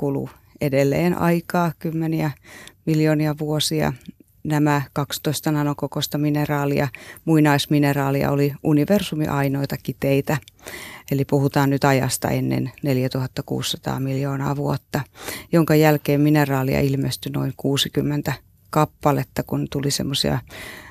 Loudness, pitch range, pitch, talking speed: -21 LUFS, 140-150 Hz, 145 Hz, 90 wpm